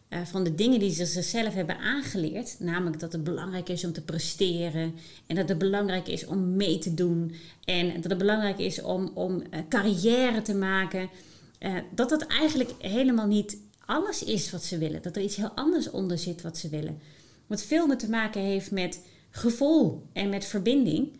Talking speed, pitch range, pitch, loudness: 195 wpm, 175-225 Hz, 195 Hz, -28 LUFS